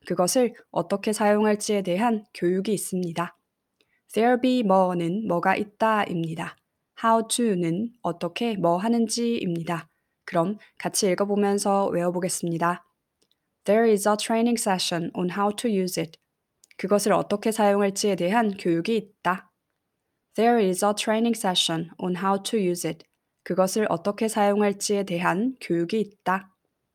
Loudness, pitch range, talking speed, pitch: -24 LUFS, 175-220 Hz, 385 characters per minute, 200 Hz